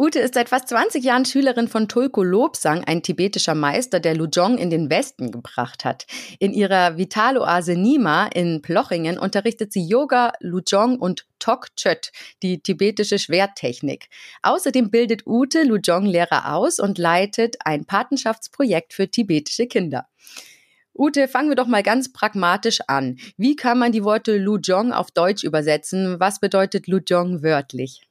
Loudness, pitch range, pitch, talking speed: -20 LUFS, 175-240 Hz, 200 Hz, 145 wpm